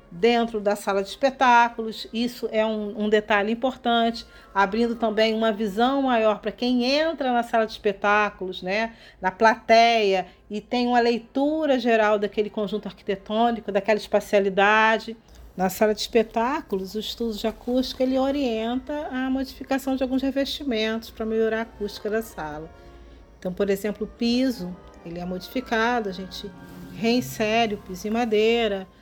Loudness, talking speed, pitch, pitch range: -23 LUFS, 150 wpm, 220 Hz, 205-240 Hz